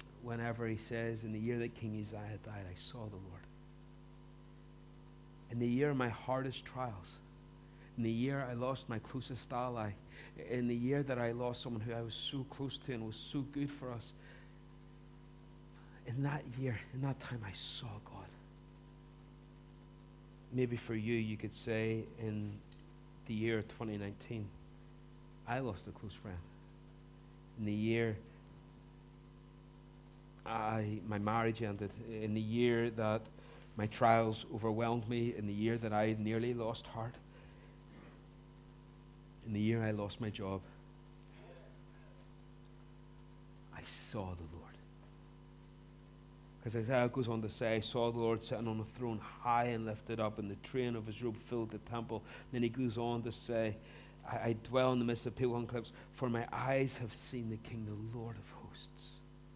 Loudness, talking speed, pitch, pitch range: -39 LUFS, 160 wpm, 115 Hz, 105-120 Hz